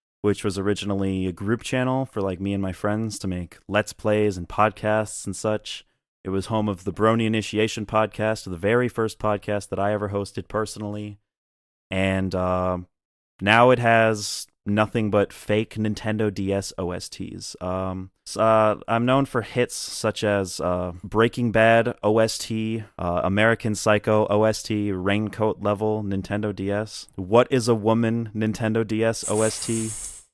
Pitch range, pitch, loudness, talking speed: 100-110 Hz, 105 Hz, -23 LUFS, 150 wpm